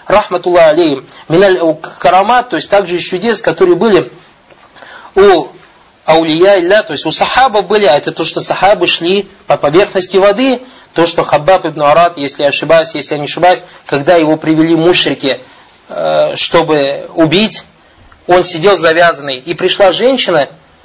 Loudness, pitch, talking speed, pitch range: -9 LUFS, 175 Hz, 145 wpm, 160-200 Hz